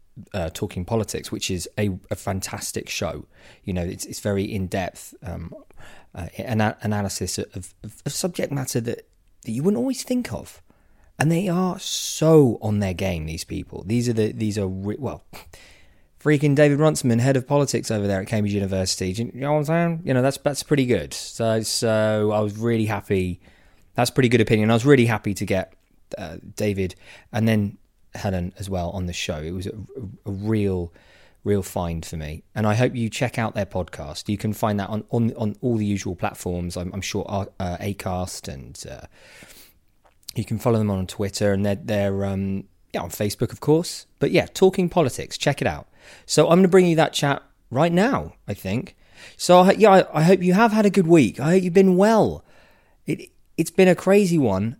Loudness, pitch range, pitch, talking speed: -22 LUFS, 95-140 Hz, 105 Hz, 195 wpm